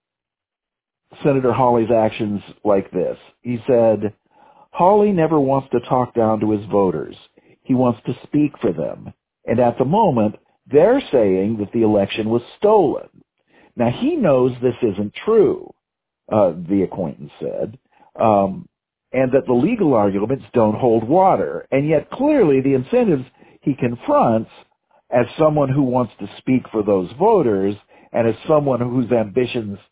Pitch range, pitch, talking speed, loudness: 110-145 Hz, 125 Hz, 145 wpm, -18 LUFS